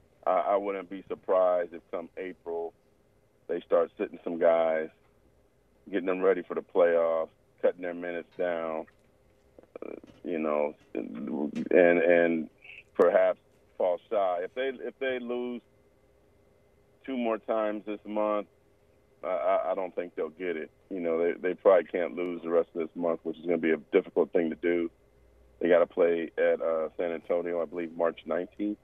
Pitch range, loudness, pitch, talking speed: 80-105 Hz, -29 LUFS, 85 Hz, 165 wpm